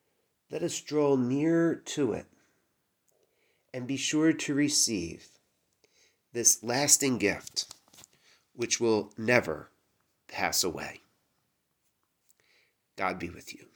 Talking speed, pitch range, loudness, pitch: 100 wpm, 115-150 Hz, -28 LUFS, 135 Hz